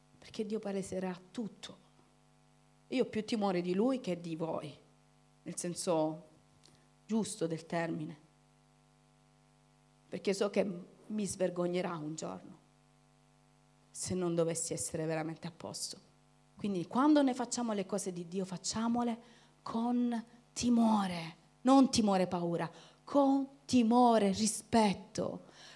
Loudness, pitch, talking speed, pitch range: -34 LUFS, 195 Hz, 115 wpm, 170-230 Hz